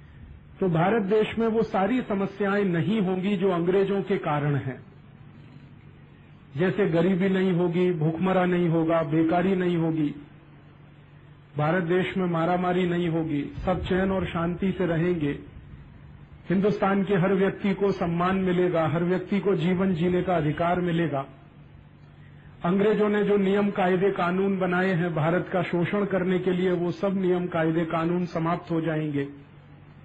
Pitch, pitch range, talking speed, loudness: 180 Hz, 165-190 Hz, 145 wpm, -25 LUFS